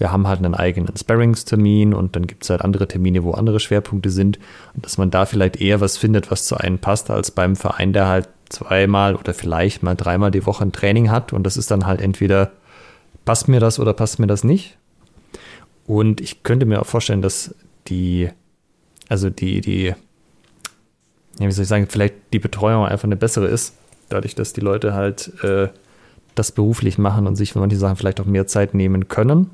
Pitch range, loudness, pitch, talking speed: 95-110 Hz, -18 LUFS, 100 Hz, 205 wpm